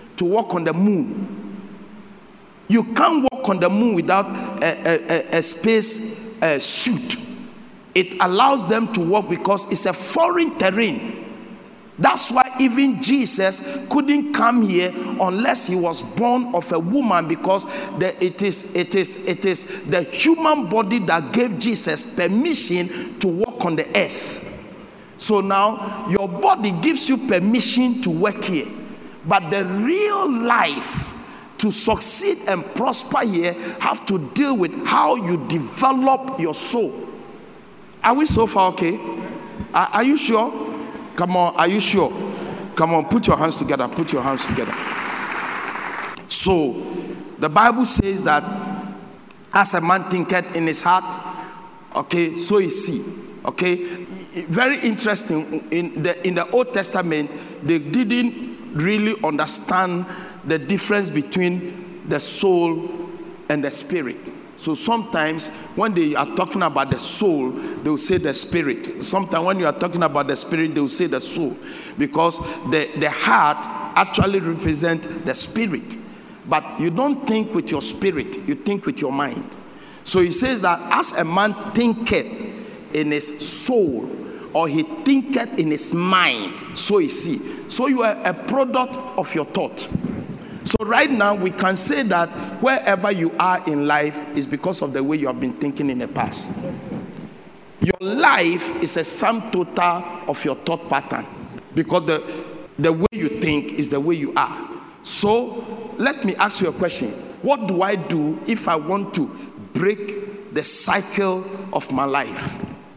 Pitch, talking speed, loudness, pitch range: 195 Hz, 155 wpm, -18 LUFS, 170-230 Hz